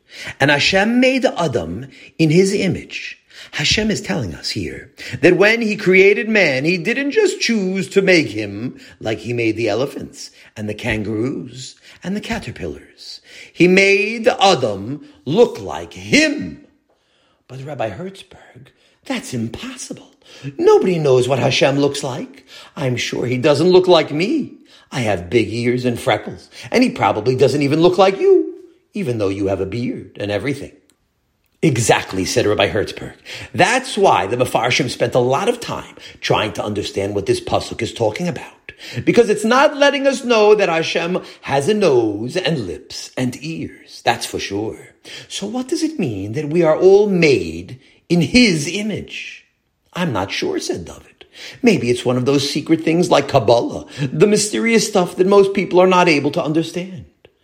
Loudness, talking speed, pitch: -16 LUFS, 165 wpm, 180 Hz